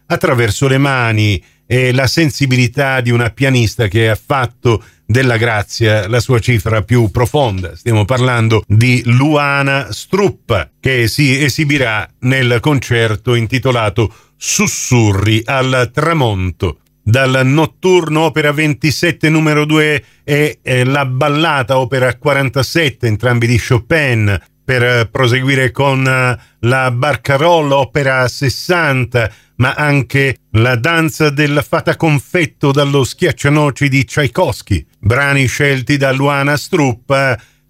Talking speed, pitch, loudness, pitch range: 110 wpm, 130 Hz, -13 LUFS, 120-145 Hz